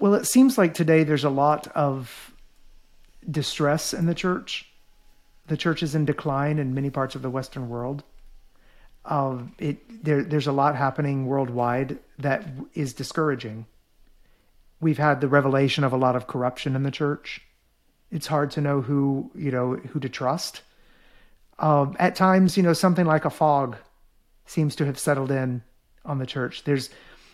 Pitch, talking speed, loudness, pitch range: 145 Hz, 165 wpm, -24 LUFS, 135-155 Hz